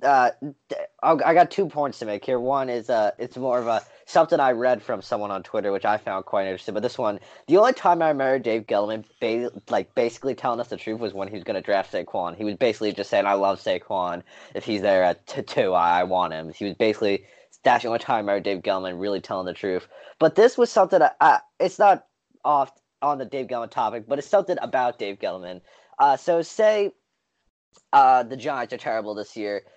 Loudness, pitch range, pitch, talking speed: -23 LUFS, 100-160 Hz, 115 Hz, 220 wpm